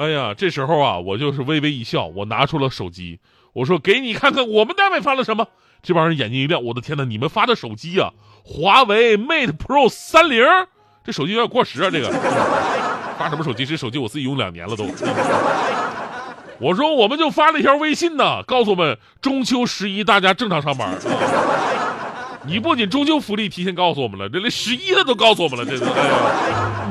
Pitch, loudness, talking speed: 190 Hz, -18 LUFS, 315 characters per minute